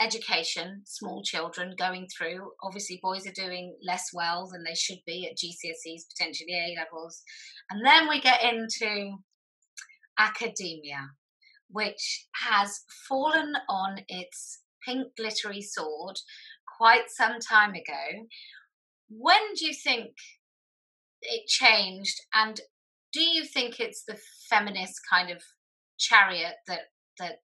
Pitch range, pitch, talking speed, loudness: 180-260 Hz, 210 Hz, 120 wpm, -26 LUFS